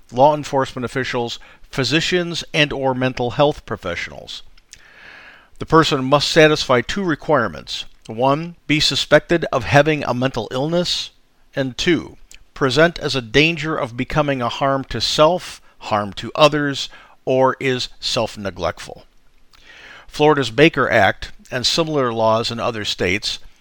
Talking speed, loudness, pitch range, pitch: 130 wpm, -18 LUFS, 125-150 Hz, 140 Hz